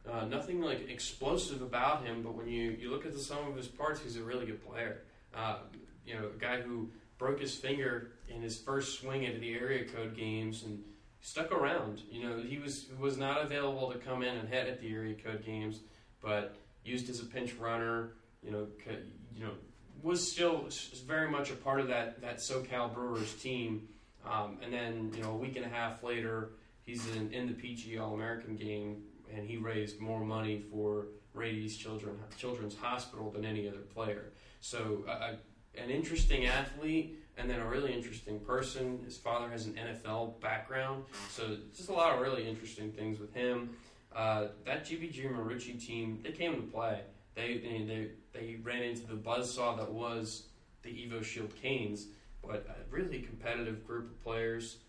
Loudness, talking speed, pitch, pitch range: -39 LUFS, 185 wpm, 115 Hz, 110-125 Hz